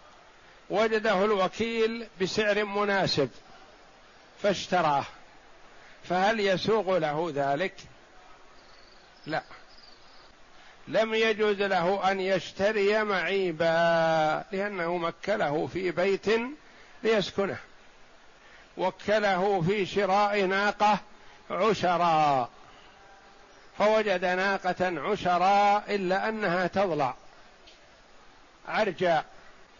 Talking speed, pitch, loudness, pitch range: 65 wpm, 195 Hz, -27 LUFS, 180-210 Hz